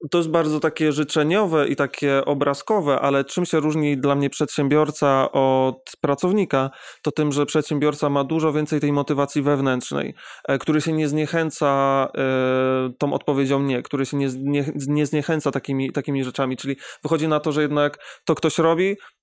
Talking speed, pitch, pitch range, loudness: 155 wpm, 145 Hz, 140-155 Hz, -21 LUFS